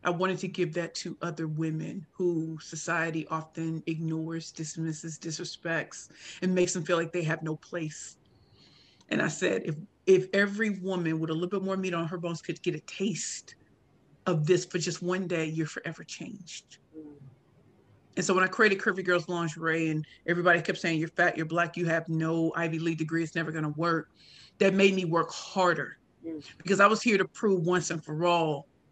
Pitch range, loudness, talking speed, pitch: 160-180 Hz, -29 LUFS, 195 wpm, 170 Hz